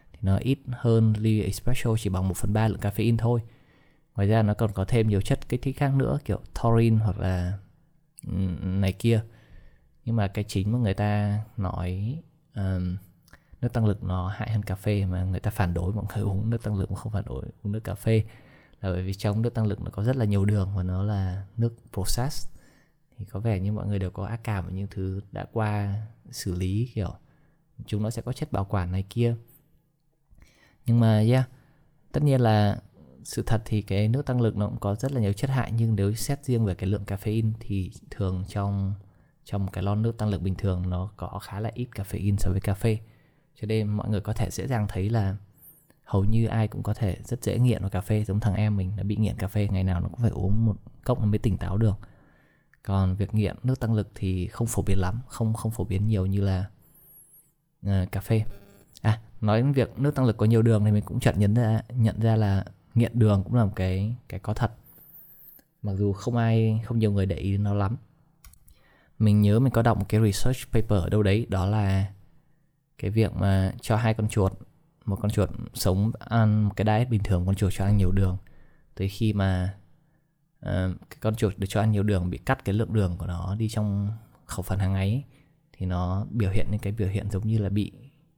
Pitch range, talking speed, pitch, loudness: 100-115 Hz, 230 wpm, 105 Hz, -27 LUFS